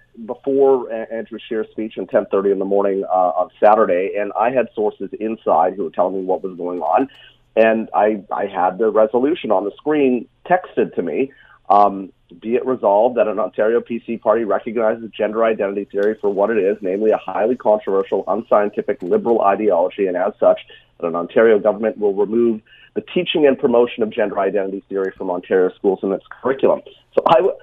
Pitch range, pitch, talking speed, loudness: 100-125 Hz, 110 Hz, 190 wpm, -18 LUFS